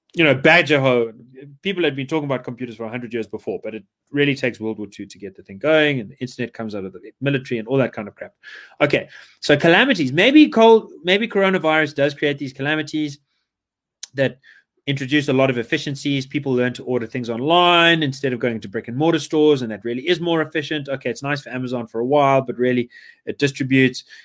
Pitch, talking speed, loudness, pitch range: 135 Hz, 220 wpm, -19 LUFS, 120-155 Hz